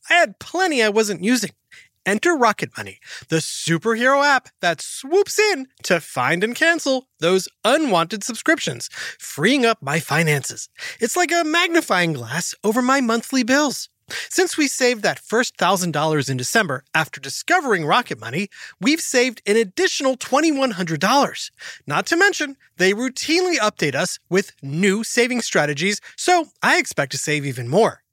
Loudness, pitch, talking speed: -19 LUFS, 225 Hz, 150 wpm